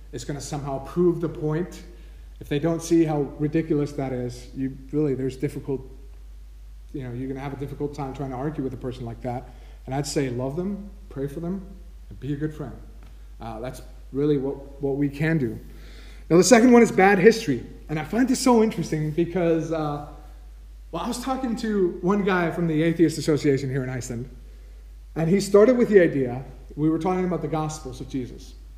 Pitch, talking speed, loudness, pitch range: 145 Hz, 210 wpm, -23 LUFS, 130-170 Hz